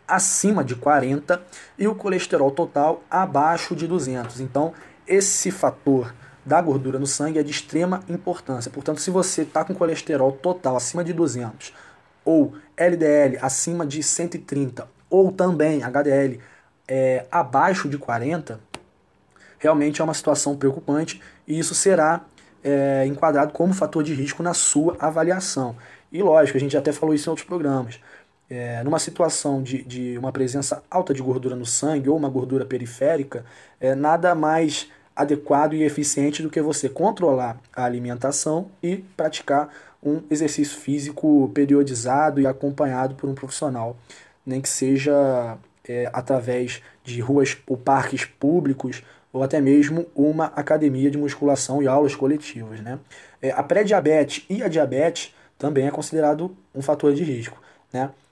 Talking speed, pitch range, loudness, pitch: 150 wpm, 135-160 Hz, -22 LUFS, 145 Hz